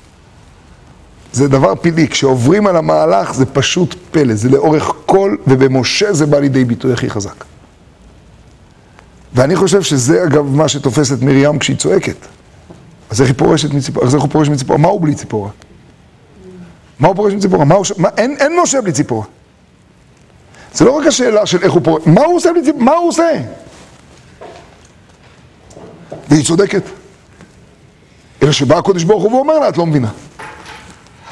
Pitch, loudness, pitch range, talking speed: 150 Hz, -12 LUFS, 135-195 Hz, 160 wpm